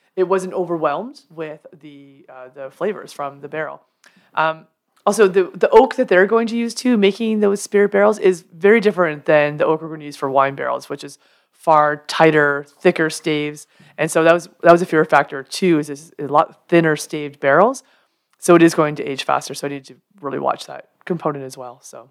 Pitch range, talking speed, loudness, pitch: 145-190 Hz, 215 wpm, -17 LUFS, 160 Hz